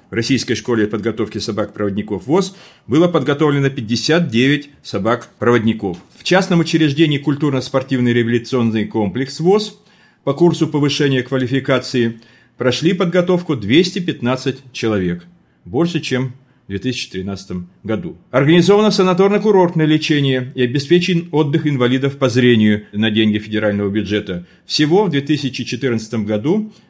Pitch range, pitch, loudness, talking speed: 115-160 Hz, 130 Hz, -16 LUFS, 105 wpm